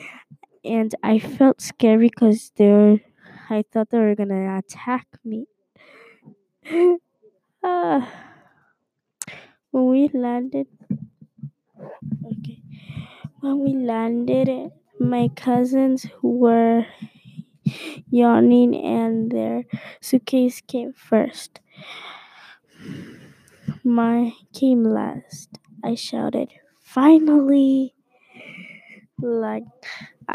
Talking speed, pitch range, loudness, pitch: 75 wpm, 215-265 Hz, -20 LUFS, 240 Hz